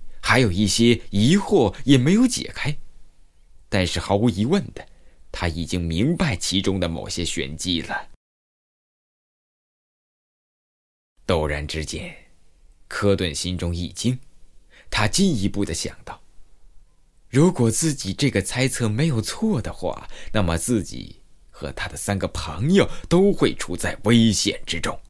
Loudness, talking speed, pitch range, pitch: -22 LUFS, 190 characters per minute, 85-125 Hz, 100 Hz